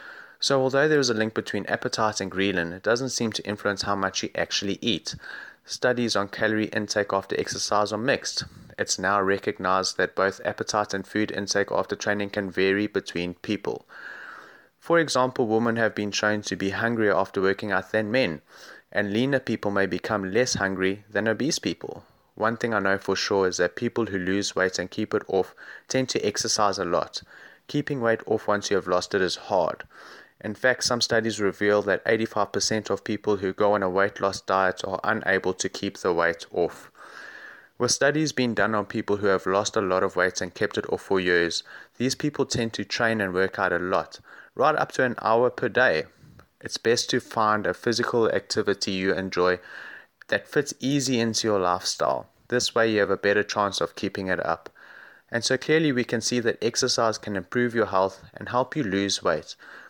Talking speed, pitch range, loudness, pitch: 200 wpm, 95-115 Hz, -25 LUFS, 105 Hz